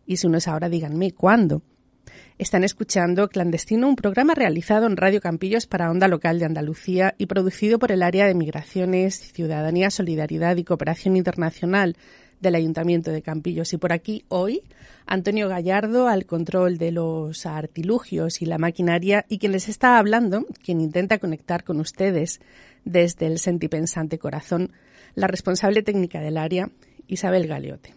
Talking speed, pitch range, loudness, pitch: 155 wpm, 165-200 Hz, -22 LUFS, 180 Hz